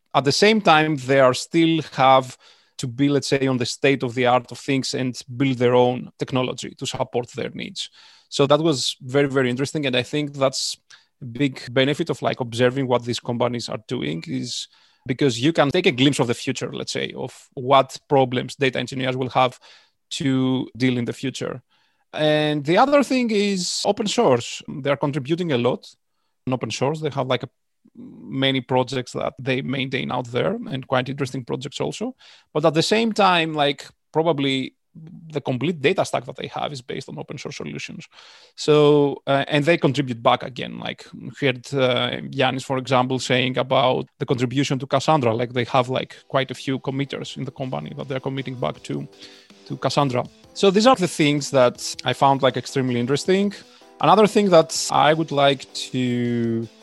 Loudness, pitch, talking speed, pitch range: -21 LUFS, 135 Hz, 190 wpm, 125-150 Hz